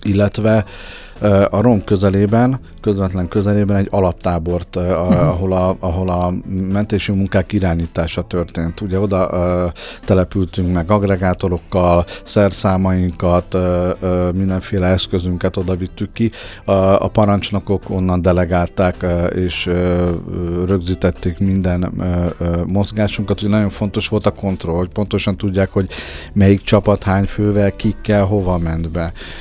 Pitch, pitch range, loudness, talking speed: 95 Hz, 90-100 Hz, -17 LUFS, 110 wpm